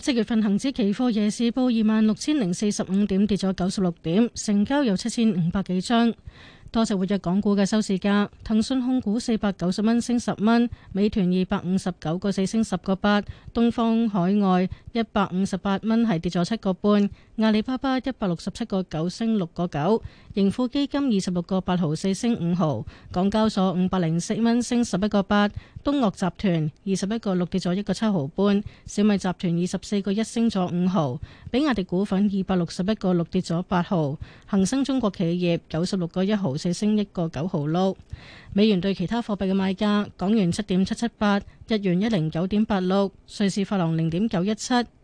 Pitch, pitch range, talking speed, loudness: 200 Hz, 185-220 Hz, 300 characters per minute, -24 LUFS